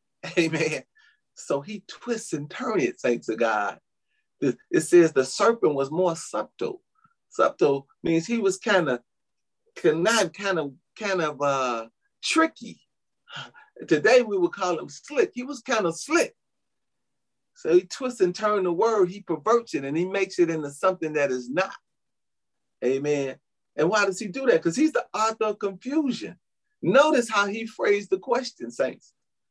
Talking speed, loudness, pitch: 165 wpm, -25 LUFS, 205 Hz